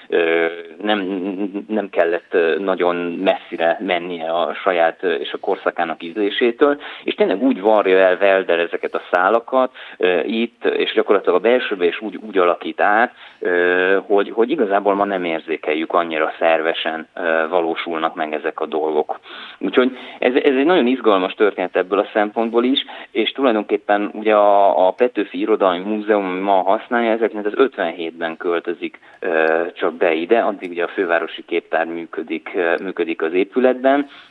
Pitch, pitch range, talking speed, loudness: 100 Hz, 85-115 Hz, 145 wpm, -18 LUFS